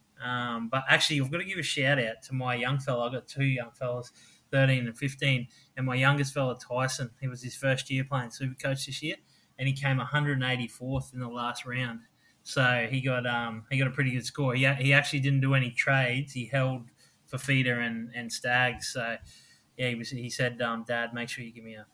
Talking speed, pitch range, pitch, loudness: 230 wpm, 120-135 Hz, 130 Hz, -29 LUFS